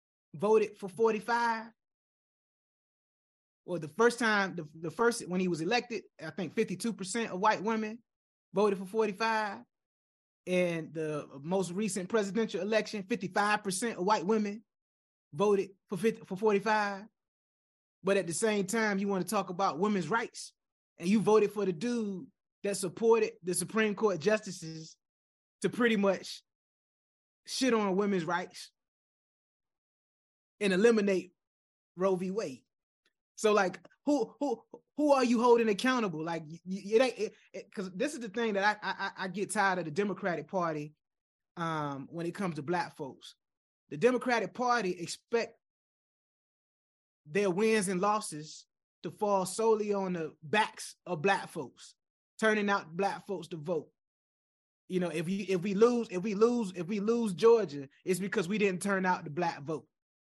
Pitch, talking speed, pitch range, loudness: 200 Hz, 155 wpm, 180-220 Hz, -31 LUFS